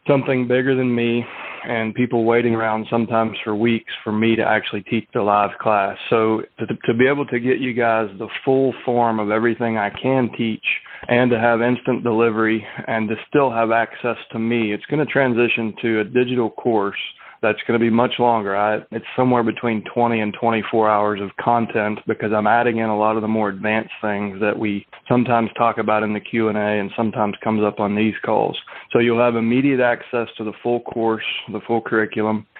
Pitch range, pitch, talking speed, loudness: 110-120 Hz, 115 Hz, 200 wpm, -19 LUFS